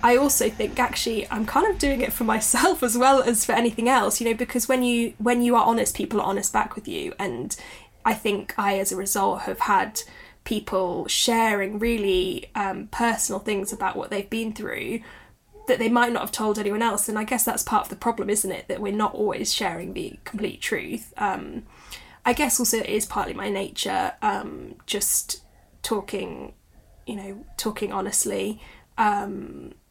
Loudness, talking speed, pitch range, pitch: -24 LUFS, 190 wpm, 205-245 Hz, 225 Hz